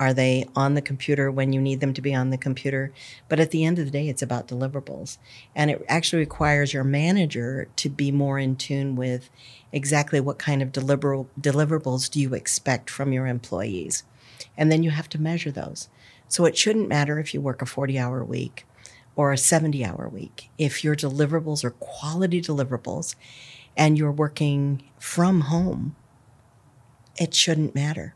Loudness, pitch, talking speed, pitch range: -24 LUFS, 140 Hz, 180 wpm, 130-150 Hz